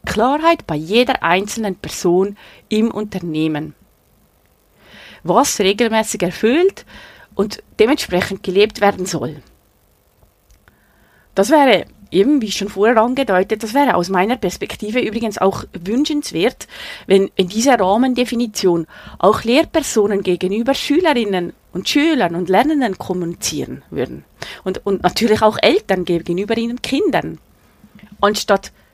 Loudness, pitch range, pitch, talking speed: -17 LUFS, 185-235 Hz, 205 Hz, 110 wpm